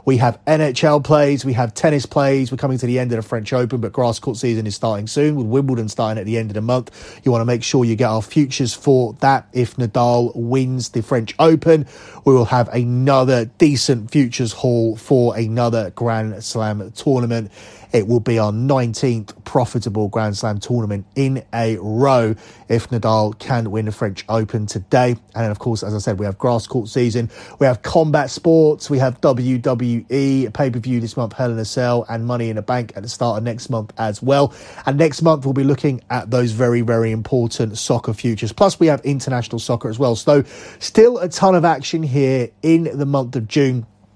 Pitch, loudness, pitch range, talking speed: 120 Hz, -18 LUFS, 115-135 Hz, 210 wpm